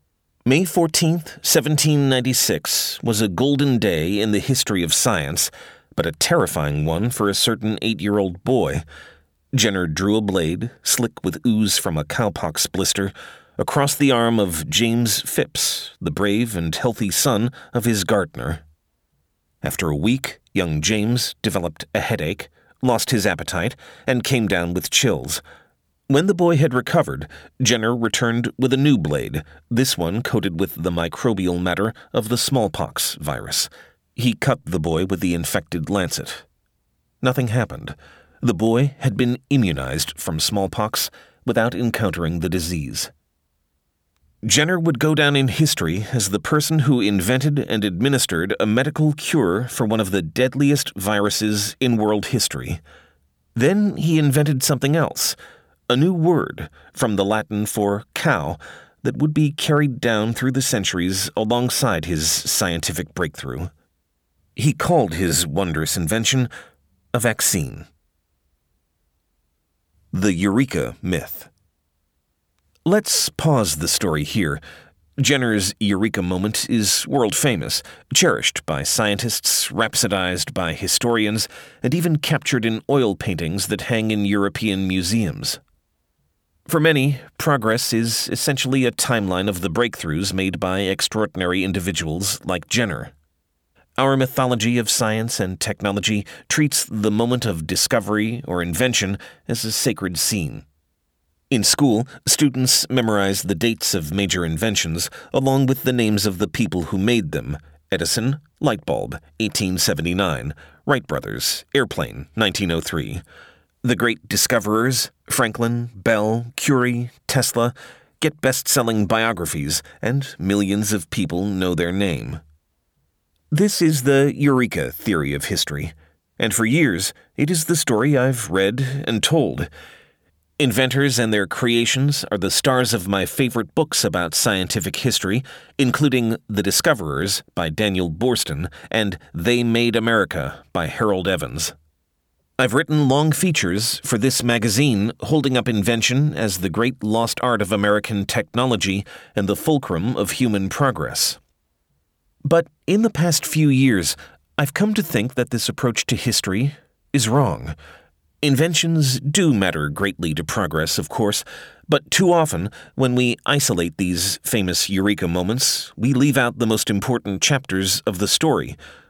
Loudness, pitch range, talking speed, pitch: -20 LUFS, 90-130 Hz, 135 wpm, 110 Hz